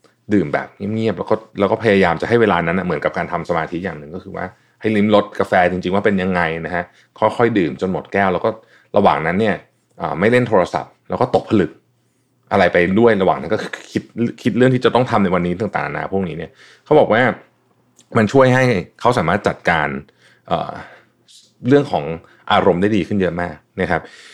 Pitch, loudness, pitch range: 105 Hz, -17 LUFS, 90-115 Hz